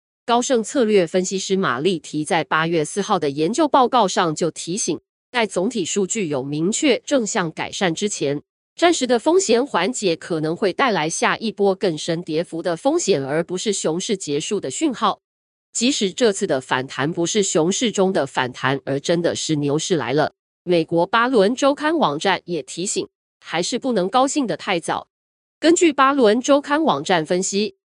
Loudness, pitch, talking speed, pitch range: -20 LUFS, 190 Hz, 265 characters per minute, 165-240 Hz